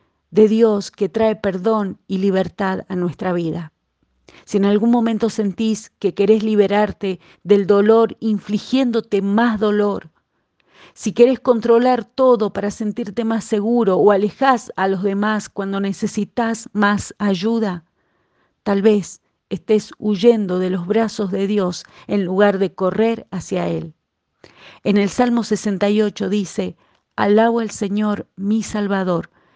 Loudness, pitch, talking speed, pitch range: -18 LUFS, 205 Hz, 130 wpm, 195-225 Hz